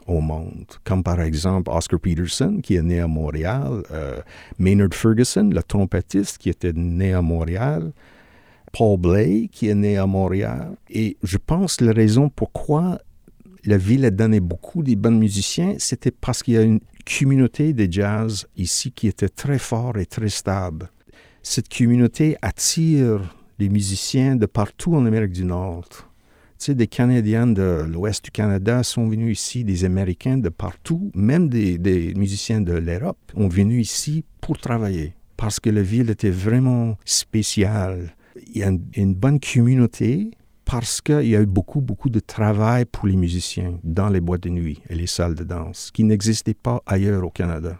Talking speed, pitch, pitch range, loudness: 175 wpm, 105 Hz, 90-120 Hz, -20 LUFS